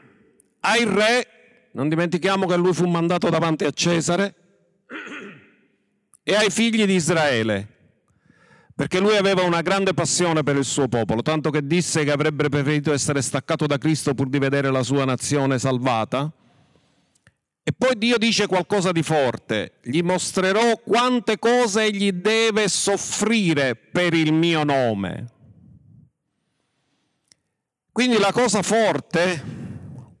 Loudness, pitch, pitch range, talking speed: -20 LUFS, 170 Hz, 145-205 Hz, 130 wpm